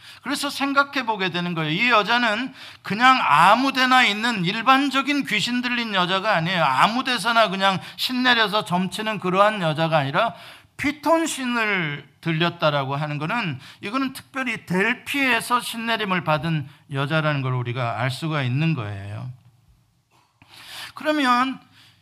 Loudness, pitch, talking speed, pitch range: -21 LUFS, 205 Hz, 300 characters per minute, 155-245 Hz